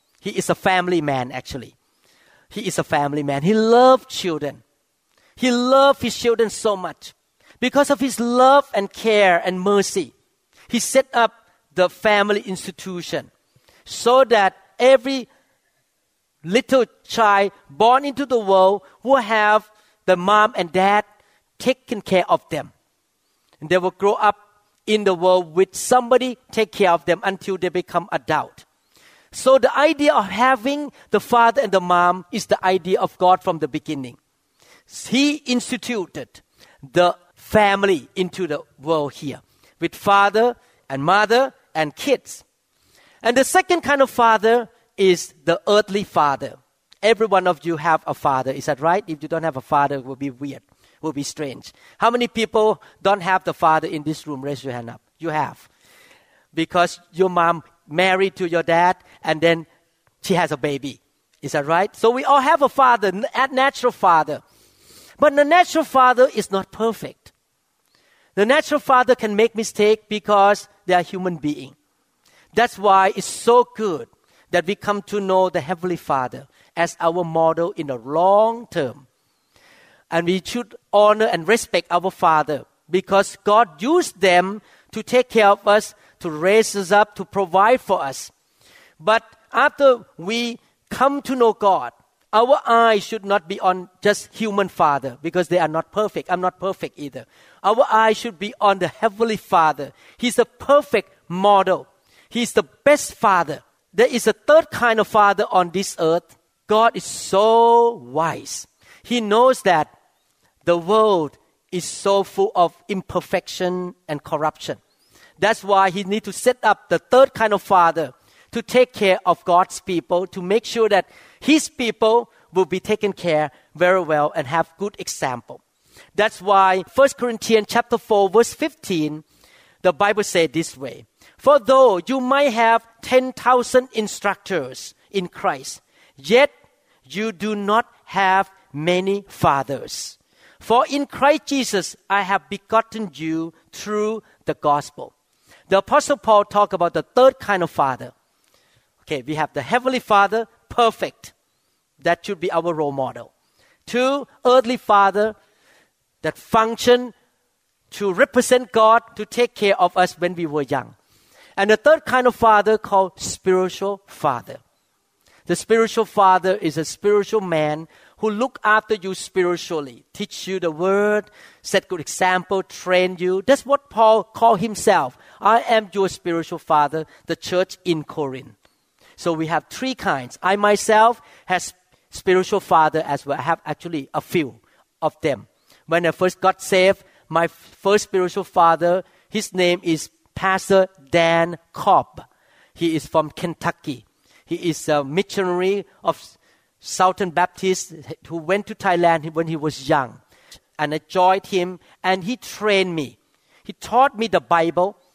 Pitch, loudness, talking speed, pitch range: 195 Hz, -19 LUFS, 155 wpm, 170-225 Hz